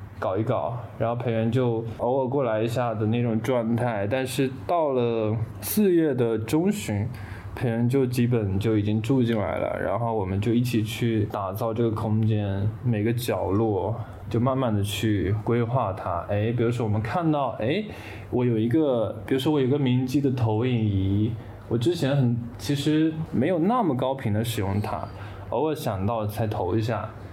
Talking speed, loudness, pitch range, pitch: 255 characters per minute, -25 LUFS, 105-125 Hz, 115 Hz